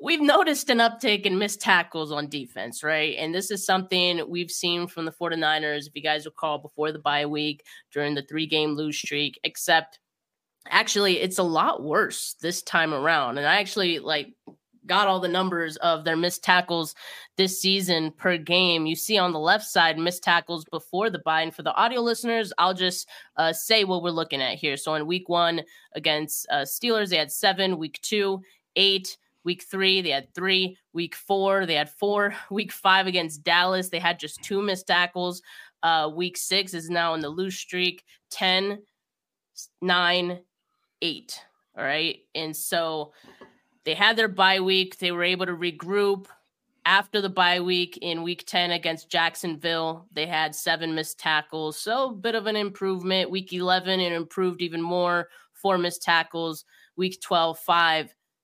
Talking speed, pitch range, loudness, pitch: 180 wpm, 160-190 Hz, -24 LUFS, 175 Hz